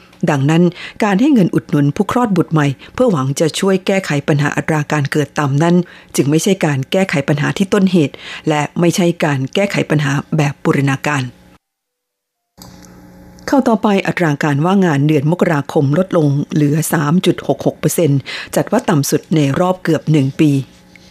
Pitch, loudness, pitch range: 155 Hz, -15 LUFS, 140-175 Hz